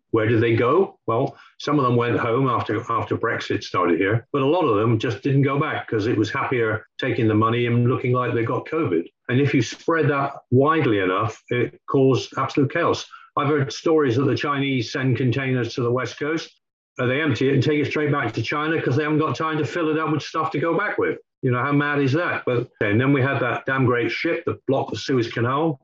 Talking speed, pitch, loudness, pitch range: 245 wpm, 140 Hz, -22 LUFS, 125-150 Hz